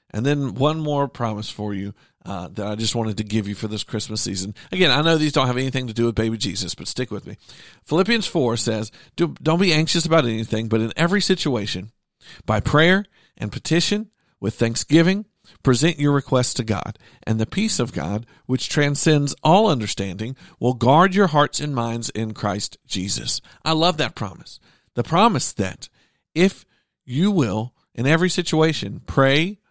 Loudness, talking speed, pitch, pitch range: -21 LUFS, 180 wpm, 130 Hz, 110-160 Hz